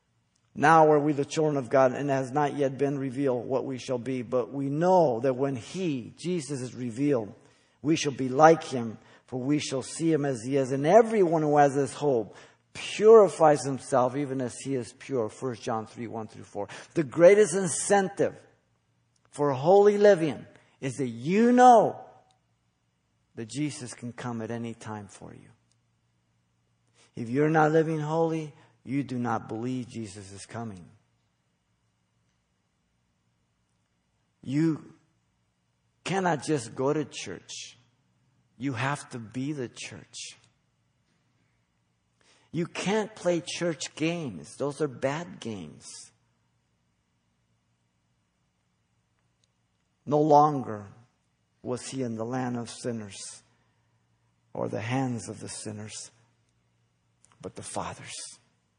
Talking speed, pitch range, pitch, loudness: 130 wpm, 110-150 Hz, 130 Hz, -26 LUFS